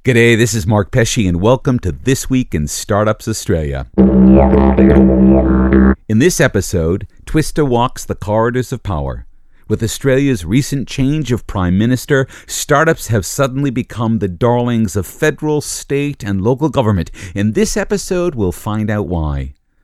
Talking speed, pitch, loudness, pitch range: 145 wpm, 110 Hz, -14 LUFS, 90-130 Hz